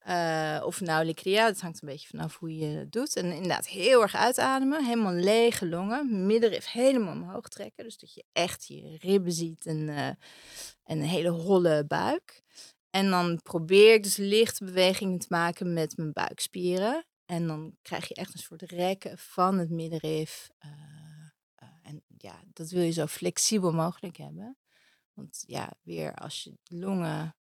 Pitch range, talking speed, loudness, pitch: 160-200 Hz, 170 wpm, -28 LUFS, 175 Hz